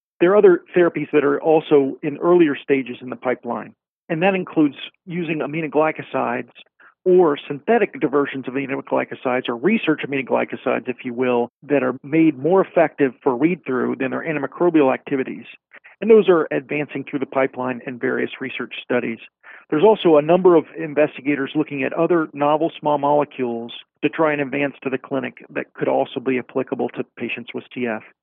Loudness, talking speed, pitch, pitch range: -20 LUFS, 170 wpm, 145 Hz, 130-160 Hz